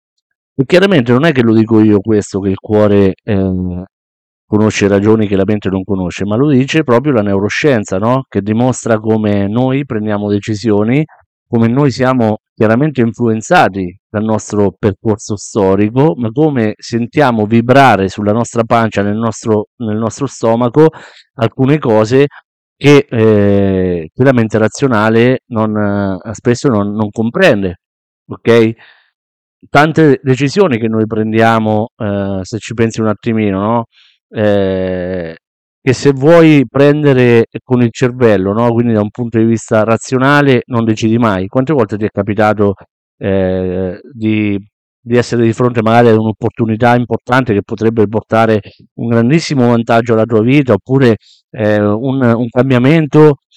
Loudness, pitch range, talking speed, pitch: -12 LUFS, 105-125 Hz, 145 wpm, 110 Hz